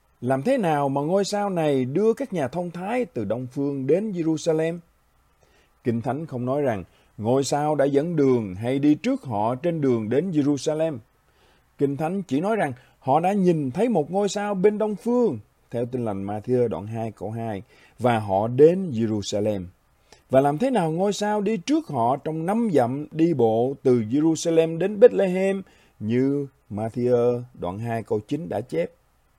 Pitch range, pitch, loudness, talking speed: 120-185 Hz, 145 Hz, -23 LUFS, 180 wpm